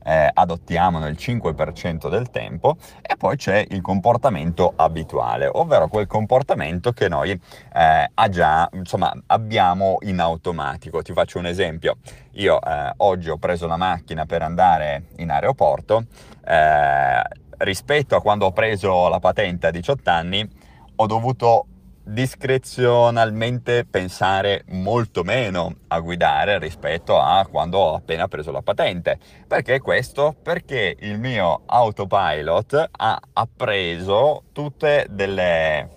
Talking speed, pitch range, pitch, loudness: 125 wpm, 90-120 Hz, 105 Hz, -20 LUFS